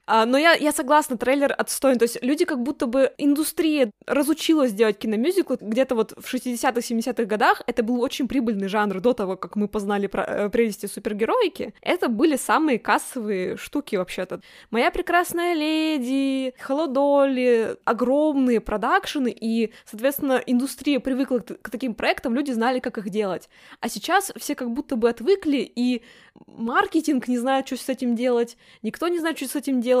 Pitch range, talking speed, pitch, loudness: 230-285 Hz, 160 wpm, 255 Hz, -23 LUFS